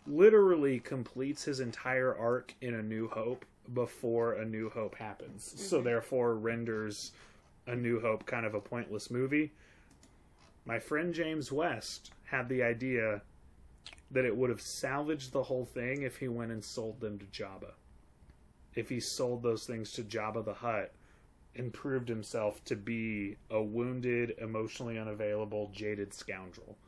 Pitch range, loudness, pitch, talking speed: 105-130 Hz, -35 LUFS, 115 Hz, 150 wpm